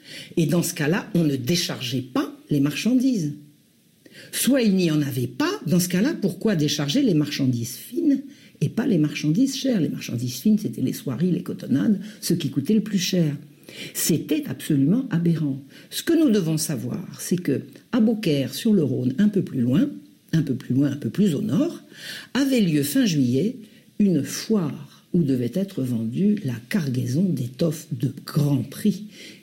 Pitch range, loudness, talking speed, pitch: 140-215 Hz, -23 LUFS, 175 wpm, 170 Hz